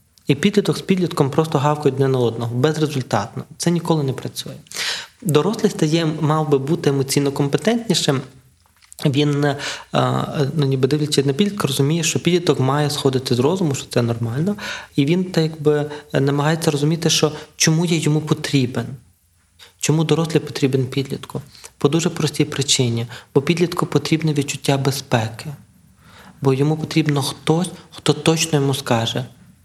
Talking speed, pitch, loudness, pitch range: 140 wpm, 145 Hz, -19 LUFS, 135-160 Hz